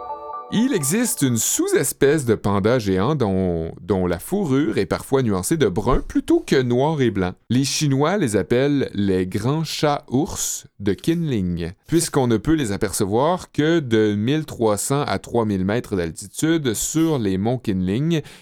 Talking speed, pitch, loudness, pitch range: 155 wpm, 125 Hz, -20 LUFS, 100-155 Hz